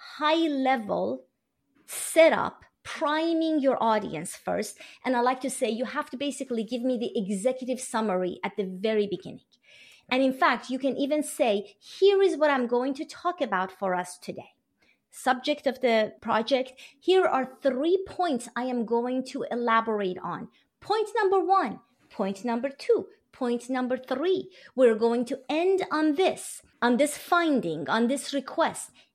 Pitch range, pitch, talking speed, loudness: 235-300 Hz, 260 Hz, 160 wpm, -27 LUFS